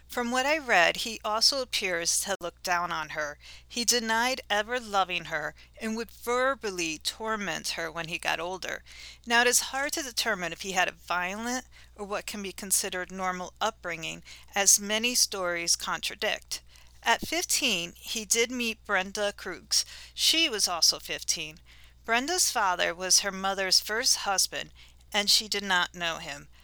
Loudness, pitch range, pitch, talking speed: -27 LUFS, 175-235 Hz, 200 Hz, 160 wpm